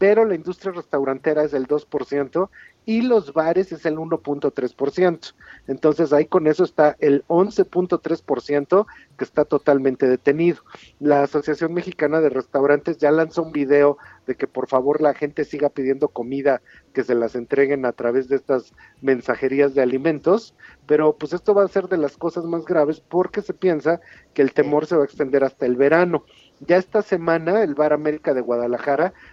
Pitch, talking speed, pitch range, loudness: 150 Hz, 175 wpm, 140-170 Hz, -20 LUFS